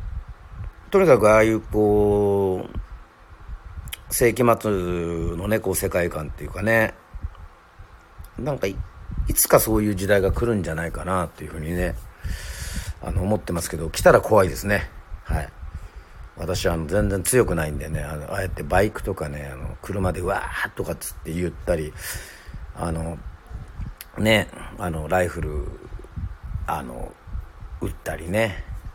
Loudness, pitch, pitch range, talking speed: -23 LUFS, 90 Hz, 80-100 Hz, 275 characters per minute